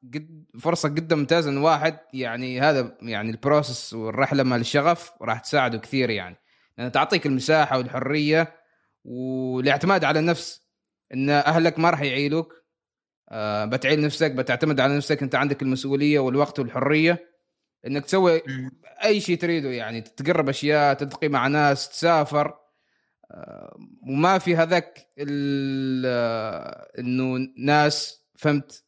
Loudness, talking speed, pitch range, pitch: -23 LUFS, 115 wpm, 130-160 Hz, 145 Hz